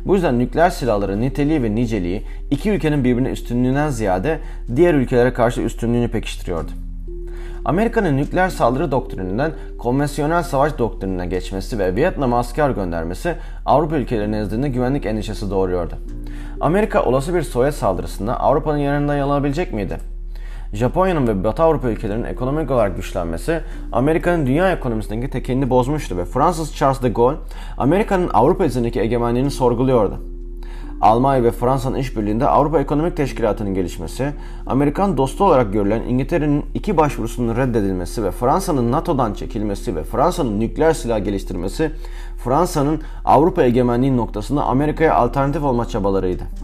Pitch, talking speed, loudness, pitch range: 125 Hz, 130 wpm, -19 LUFS, 105-145 Hz